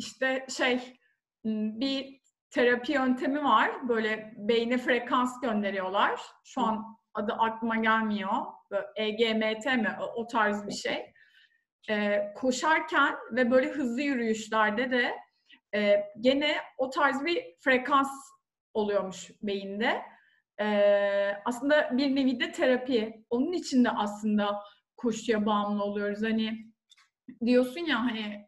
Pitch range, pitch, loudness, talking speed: 215-265 Hz, 230 Hz, -28 LUFS, 115 wpm